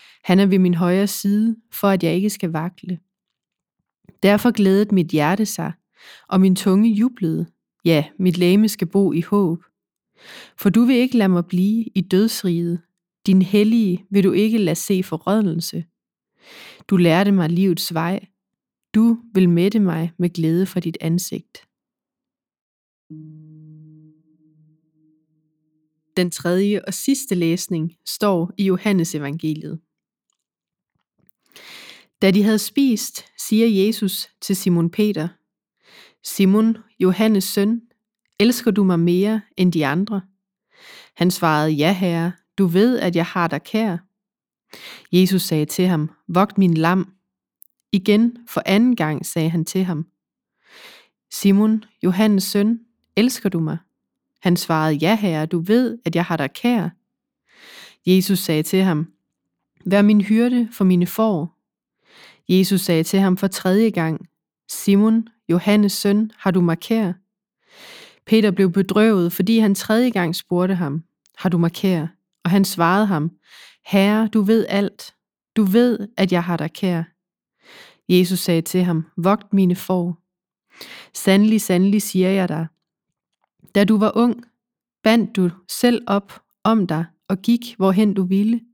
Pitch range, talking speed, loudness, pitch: 170-210 Hz, 140 wpm, -19 LUFS, 190 Hz